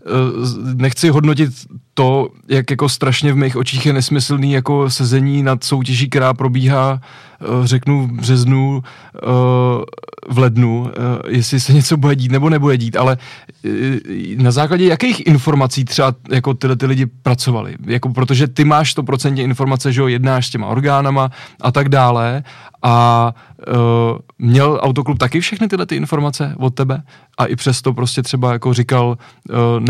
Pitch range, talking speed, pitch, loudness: 125-140 Hz, 145 wpm, 130 Hz, -15 LUFS